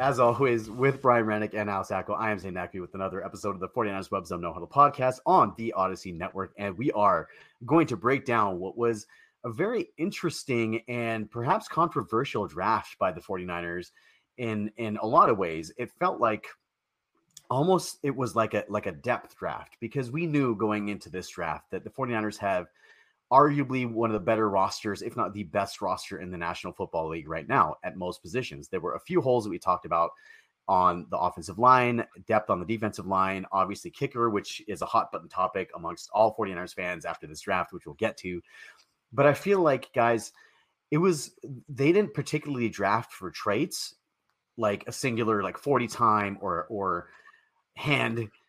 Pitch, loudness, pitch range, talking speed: 110 Hz, -28 LUFS, 95-130 Hz, 190 wpm